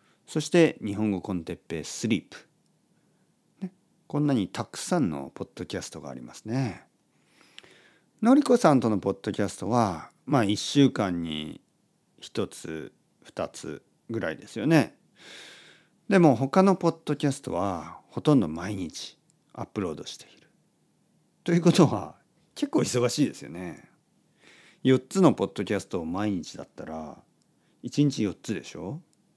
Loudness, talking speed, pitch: -26 LUFS, 270 characters per minute, 130 Hz